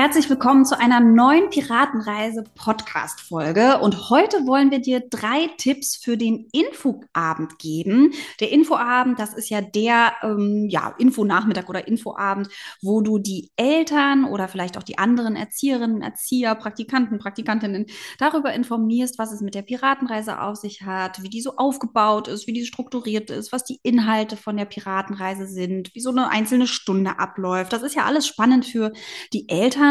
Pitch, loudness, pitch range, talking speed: 225 Hz, -21 LUFS, 205-255 Hz, 170 wpm